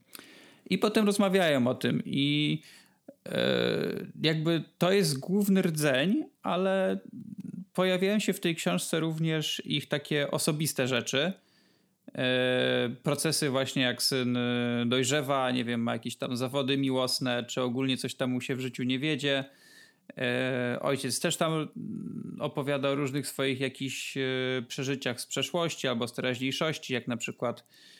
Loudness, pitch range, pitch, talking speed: -29 LUFS, 130-175 Hz, 140 Hz, 135 wpm